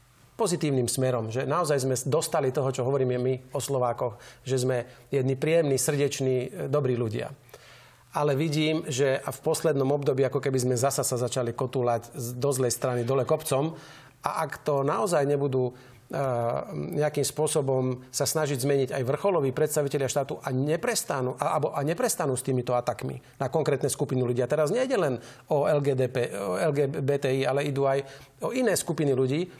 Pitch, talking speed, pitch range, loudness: 135 Hz, 160 wpm, 130-150 Hz, -27 LUFS